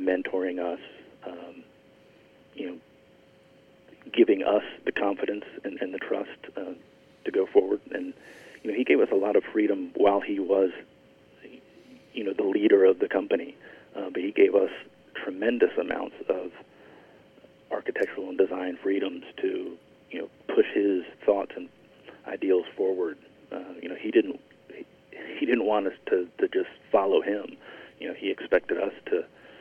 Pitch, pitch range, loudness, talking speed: 385 Hz, 275-425 Hz, -27 LUFS, 160 wpm